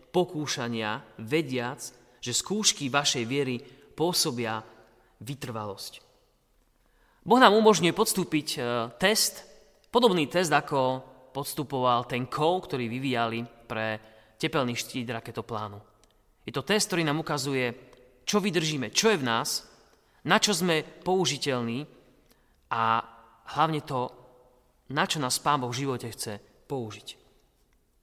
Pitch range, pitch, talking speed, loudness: 115-160 Hz, 130 Hz, 115 wpm, -27 LUFS